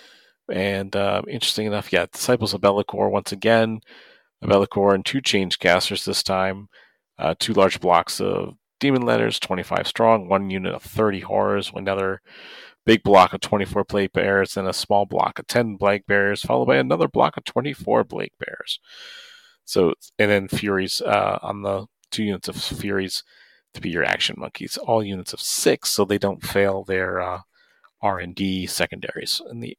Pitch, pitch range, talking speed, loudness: 100 Hz, 95-110 Hz, 175 wpm, -21 LUFS